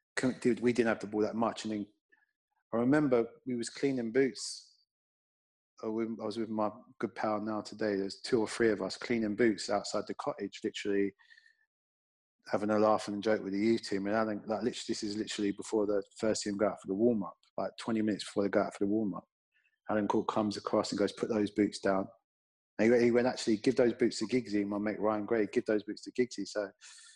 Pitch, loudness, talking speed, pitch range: 110 Hz, -33 LUFS, 230 wpm, 105-120 Hz